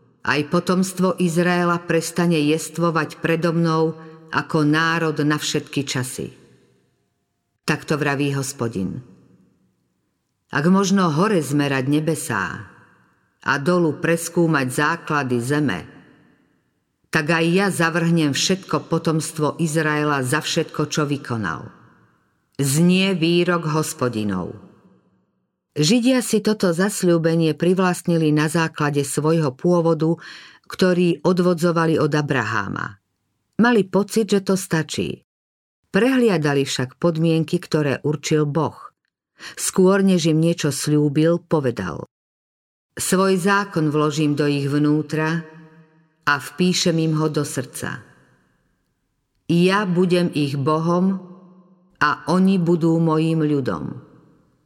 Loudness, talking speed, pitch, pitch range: -20 LUFS, 100 wpm, 160 Hz, 145-175 Hz